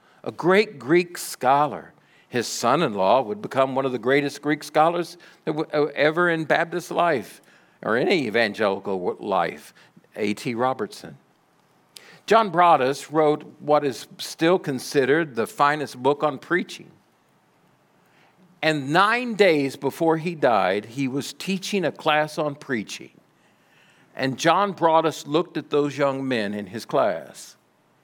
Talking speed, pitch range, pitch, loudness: 130 wpm, 140-175 Hz, 150 Hz, -22 LUFS